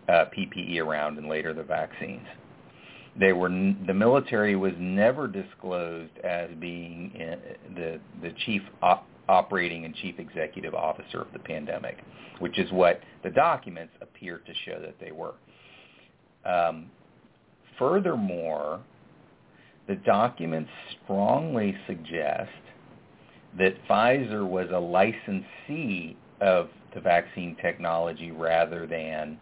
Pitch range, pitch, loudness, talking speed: 80-95 Hz, 85 Hz, -27 LUFS, 120 wpm